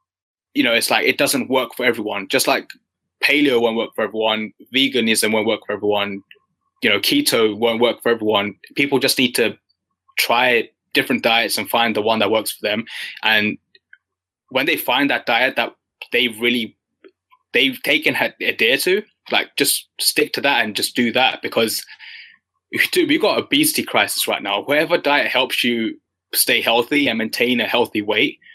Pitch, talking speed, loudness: 140 Hz, 180 wpm, -18 LUFS